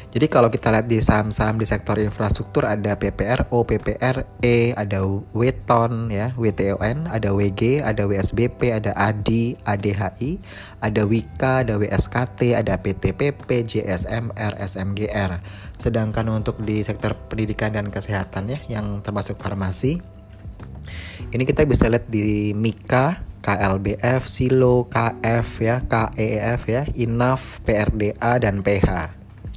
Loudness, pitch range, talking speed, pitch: -21 LUFS, 100-120 Hz, 120 wpm, 105 Hz